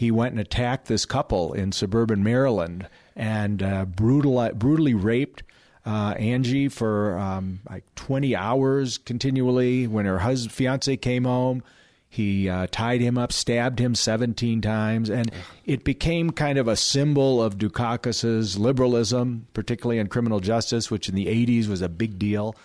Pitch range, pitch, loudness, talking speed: 105-125 Hz, 115 Hz, -24 LUFS, 155 wpm